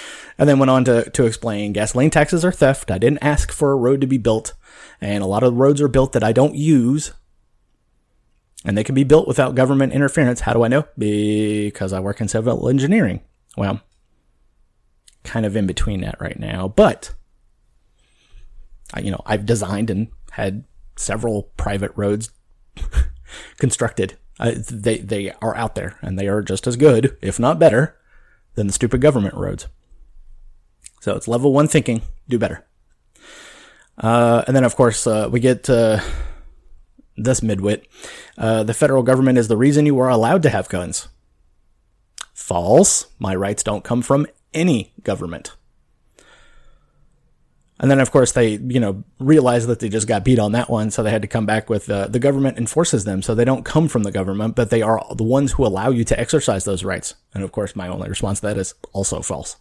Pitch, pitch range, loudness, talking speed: 115 Hz, 100-130 Hz, -18 LUFS, 185 wpm